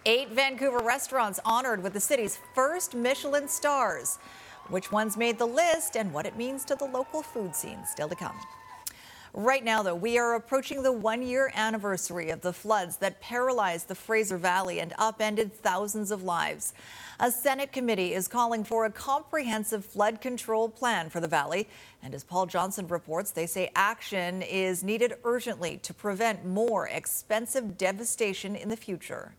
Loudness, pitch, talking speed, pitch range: -29 LUFS, 220 Hz, 170 wpm, 190-245 Hz